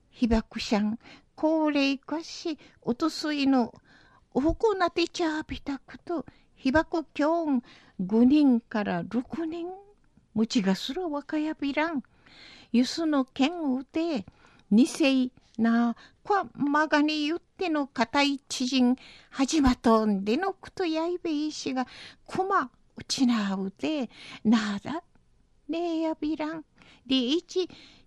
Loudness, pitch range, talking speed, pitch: -27 LUFS, 245-320 Hz, 210 characters per minute, 280 Hz